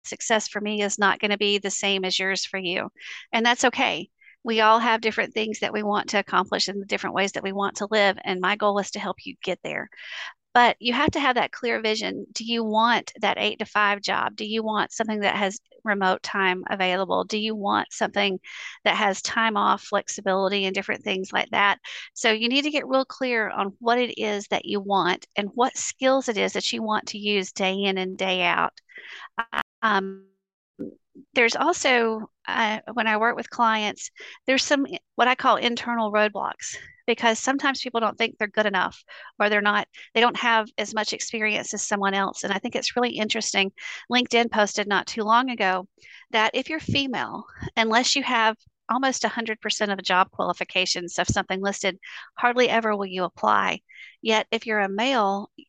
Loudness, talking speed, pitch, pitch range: -23 LUFS, 205 wpm, 215 Hz, 200-235 Hz